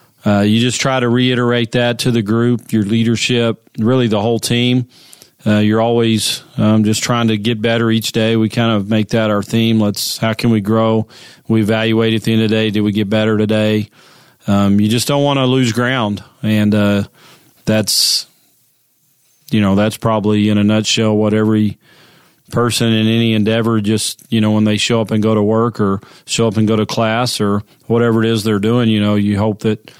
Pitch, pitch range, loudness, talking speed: 110 Hz, 105-120 Hz, -14 LUFS, 210 wpm